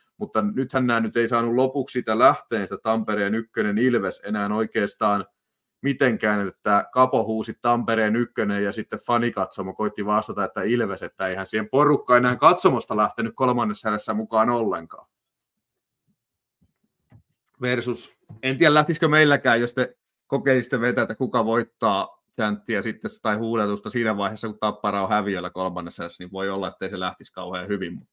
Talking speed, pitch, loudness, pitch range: 155 wpm, 110 Hz, -23 LUFS, 100-125 Hz